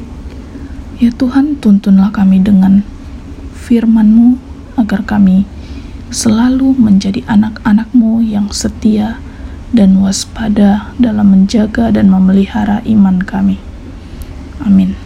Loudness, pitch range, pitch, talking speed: -10 LUFS, 195-230 Hz, 210 Hz, 90 wpm